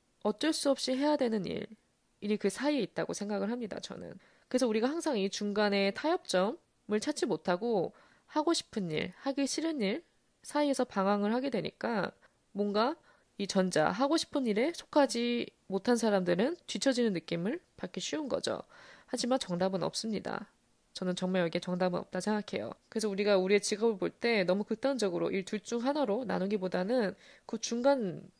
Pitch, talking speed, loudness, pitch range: 220 Hz, 350 characters per minute, -32 LUFS, 195-260 Hz